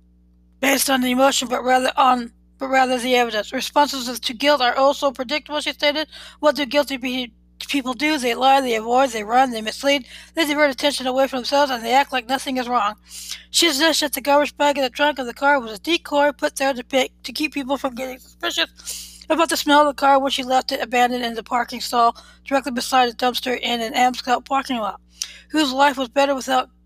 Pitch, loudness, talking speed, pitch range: 265 Hz, -19 LUFS, 225 wpm, 245-285 Hz